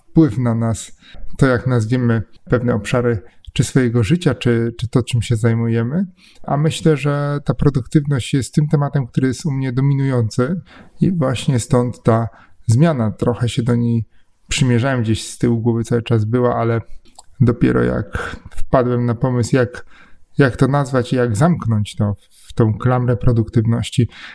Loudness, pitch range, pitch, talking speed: -18 LUFS, 115-140 Hz, 120 Hz, 160 wpm